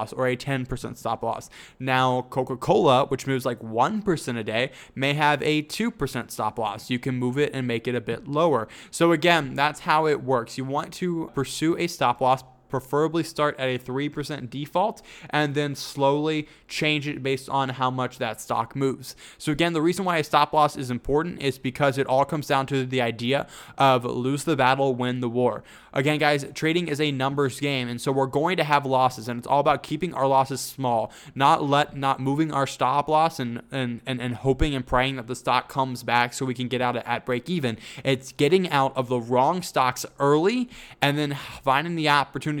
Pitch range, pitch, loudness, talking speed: 125-150 Hz, 135 Hz, -24 LUFS, 210 wpm